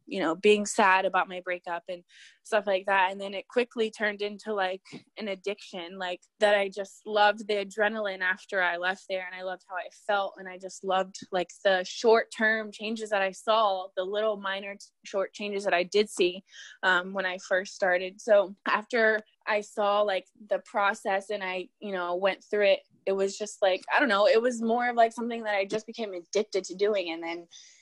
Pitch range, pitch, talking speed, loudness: 185-215 Hz, 200 Hz, 215 wpm, -28 LUFS